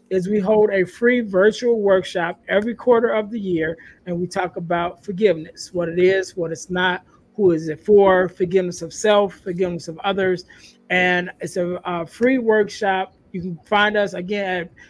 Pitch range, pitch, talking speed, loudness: 175-205 Hz, 185 Hz, 180 wpm, -20 LUFS